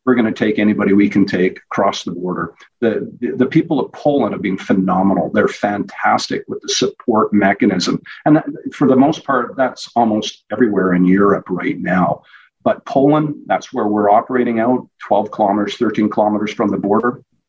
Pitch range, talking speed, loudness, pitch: 100-130 Hz, 180 wpm, -16 LUFS, 110 Hz